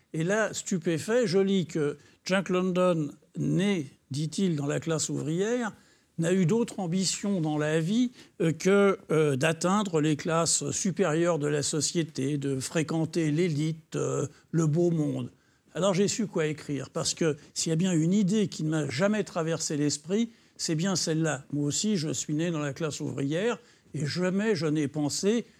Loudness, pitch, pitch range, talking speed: -28 LUFS, 165 Hz, 150-190 Hz, 170 wpm